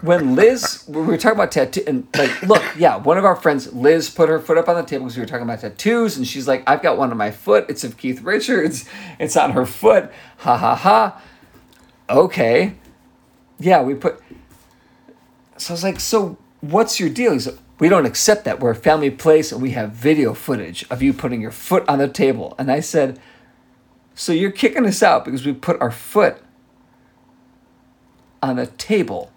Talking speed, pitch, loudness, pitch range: 205 wpm, 155 Hz, -17 LUFS, 130-195 Hz